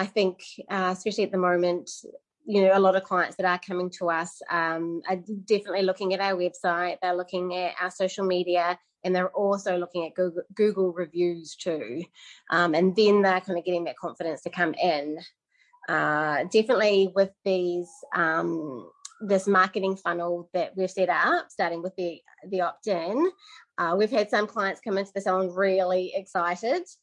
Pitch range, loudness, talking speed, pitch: 175-195 Hz, -26 LUFS, 180 wpm, 185 Hz